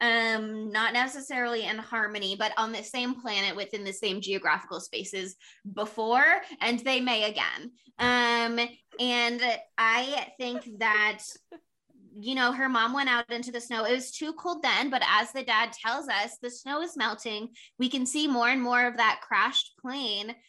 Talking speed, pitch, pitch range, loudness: 175 wpm, 235 Hz, 220-255 Hz, -27 LUFS